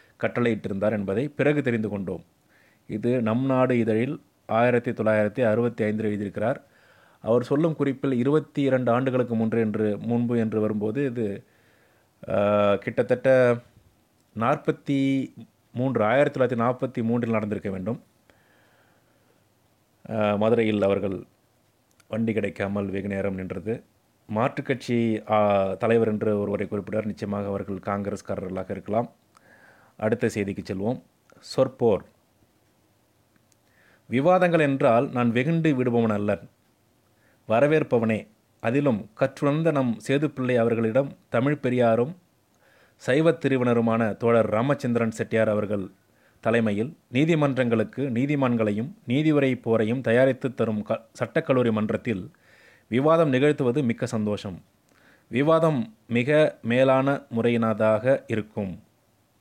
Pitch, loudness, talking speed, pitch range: 115 Hz, -24 LUFS, 95 wpm, 105-130 Hz